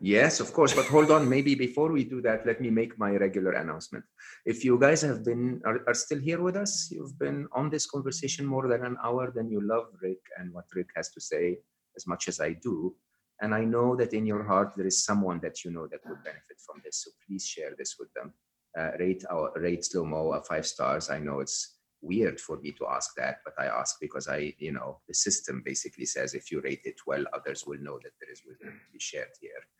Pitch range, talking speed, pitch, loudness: 110-180 Hz, 240 wpm, 125 Hz, -29 LUFS